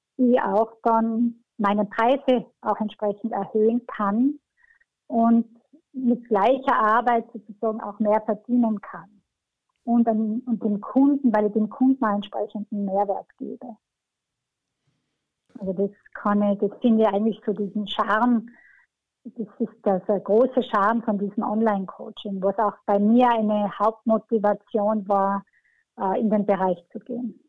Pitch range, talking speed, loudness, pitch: 205-235 Hz, 135 wpm, -23 LUFS, 220 Hz